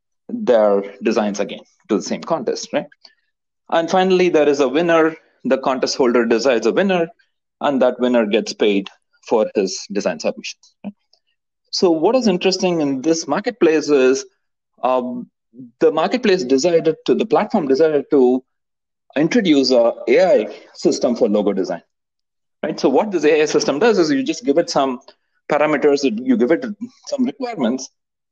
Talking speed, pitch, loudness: 155 wpm, 175 Hz, -17 LUFS